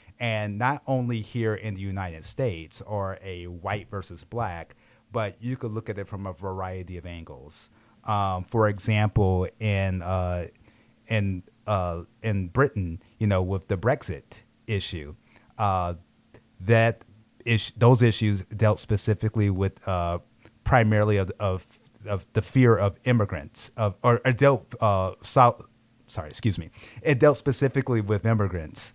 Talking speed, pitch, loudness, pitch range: 145 wpm, 105 Hz, -26 LUFS, 95-115 Hz